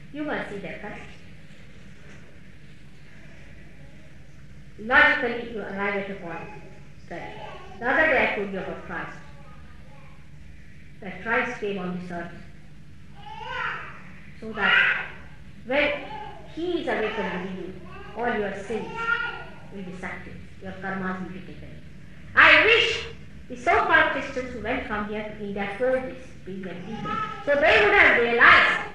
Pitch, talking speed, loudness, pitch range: 210 Hz, 135 wpm, -22 LUFS, 185-290 Hz